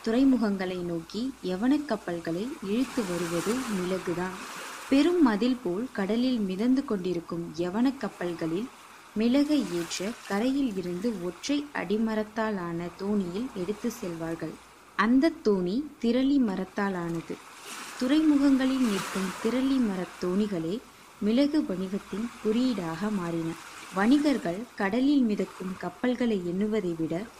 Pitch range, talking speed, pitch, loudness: 180-250 Hz, 95 wpm, 210 Hz, -28 LUFS